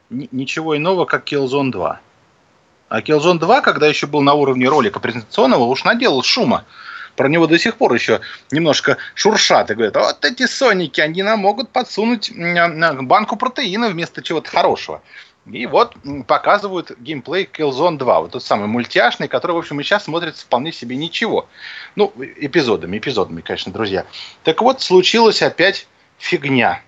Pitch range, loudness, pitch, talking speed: 145-205 Hz, -16 LUFS, 170 Hz, 155 wpm